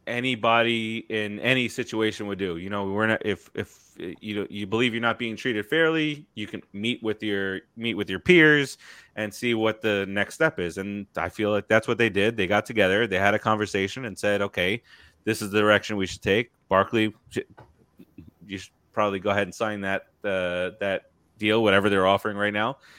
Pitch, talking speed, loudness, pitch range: 105 Hz, 205 wpm, -24 LUFS, 100-115 Hz